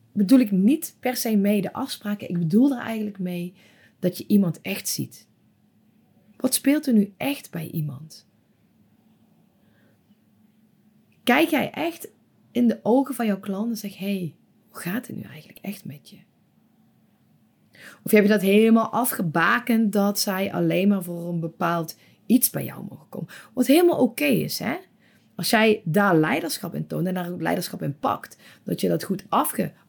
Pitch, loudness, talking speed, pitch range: 205 Hz, -23 LUFS, 175 wpm, 185-240 Hz